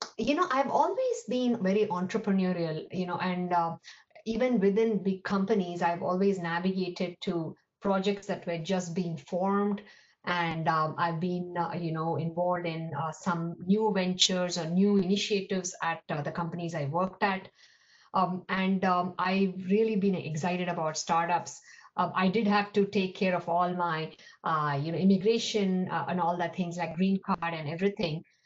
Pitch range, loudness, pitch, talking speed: 170-200 Hz, -29 LUFS, 180 Hz, 170 wpm